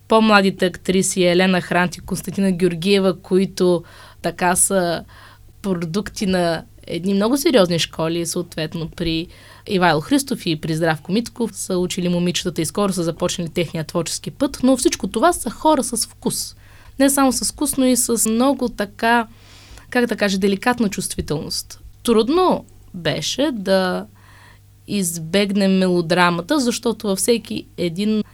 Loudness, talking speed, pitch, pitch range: -19 LUFS, 135 wpm, 190 Hz, 170-225 Hz